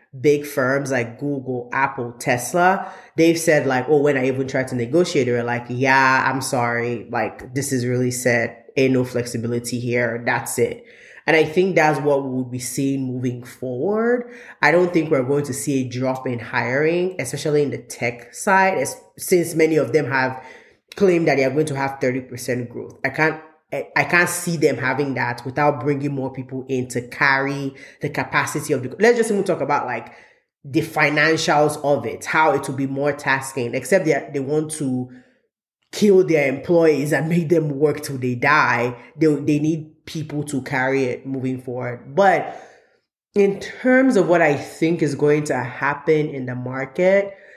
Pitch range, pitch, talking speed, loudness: 130-155 Hz, 140 Hz, 185 wpm, -20 LUFS